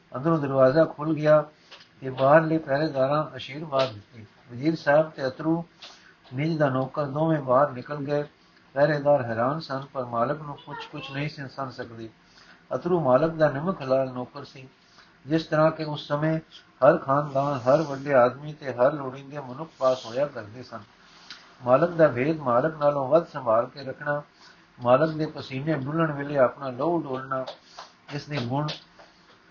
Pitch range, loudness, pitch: 130-155 Hz, -25 LUFS, 145 Hz